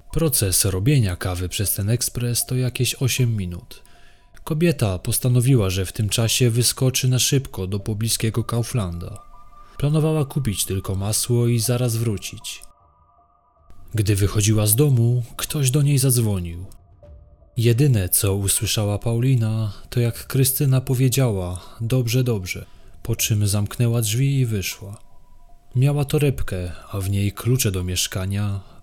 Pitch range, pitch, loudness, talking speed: 100-125 Hz, 115 Hz, -21 LUFS, 125 wpm